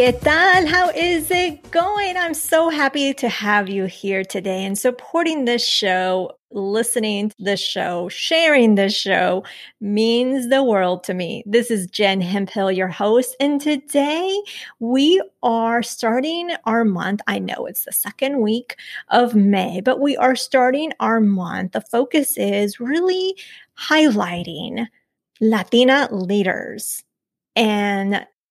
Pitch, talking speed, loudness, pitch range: 235 Hz, 135 wpm, -18 LUFS, 200-285 Hz